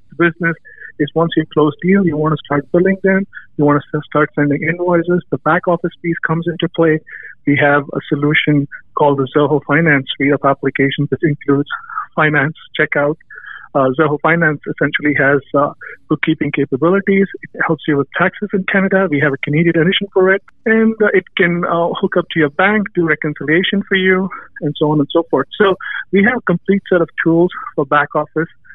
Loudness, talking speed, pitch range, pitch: -15 LUFS, 195 wpm, 145-180 Hz, 160 Hz